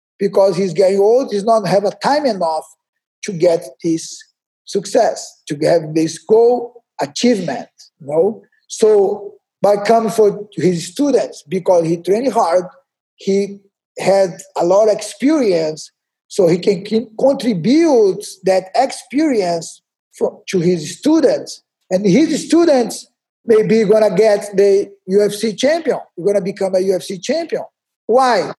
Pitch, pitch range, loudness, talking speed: 205 Hz, 185-245 Hz, -15 LUFS, 135 wpm